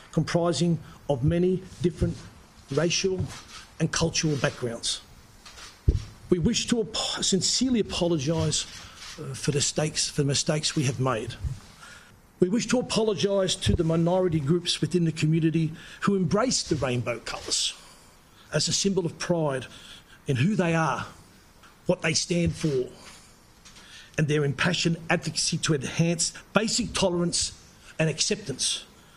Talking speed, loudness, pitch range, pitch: 125 wpm, -26 LUFS, 145-180 Hz, 165 Hz